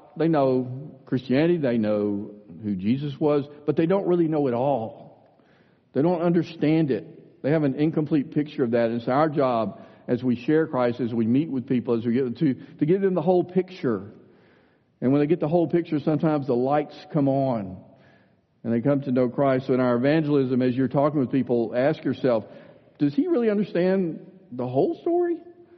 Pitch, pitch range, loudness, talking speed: 145 Hz, 125-160 Hz, -24 LUFS, 200 wpm